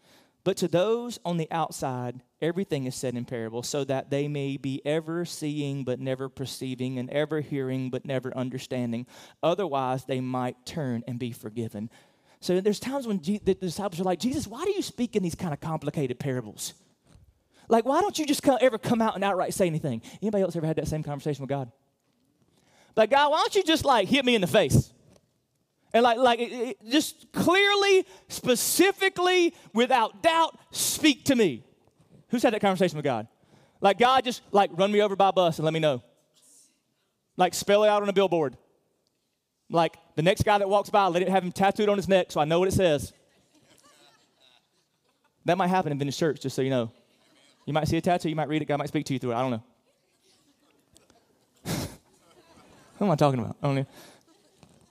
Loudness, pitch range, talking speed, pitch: -26 LUFS, 135-210 Hz, 205 wpm, 170 Hz